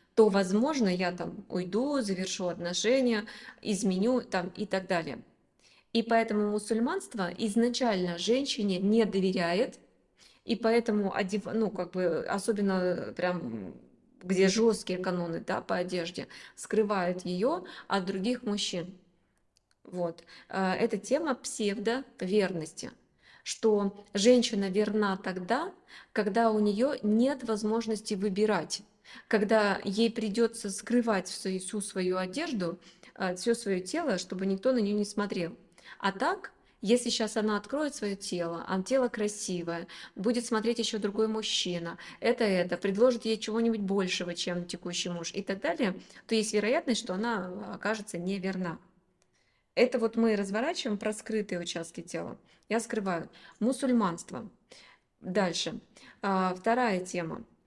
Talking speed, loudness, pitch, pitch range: 120 wpm, -30 LUFS, 210 Hz, 185-230 Hz